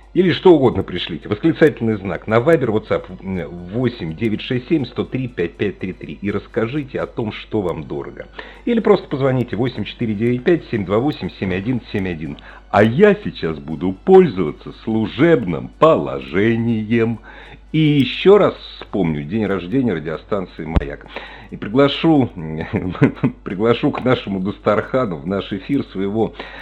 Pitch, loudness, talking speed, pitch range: 115 Hz, -18 LUFS, 115 wpm, 100-140 Hz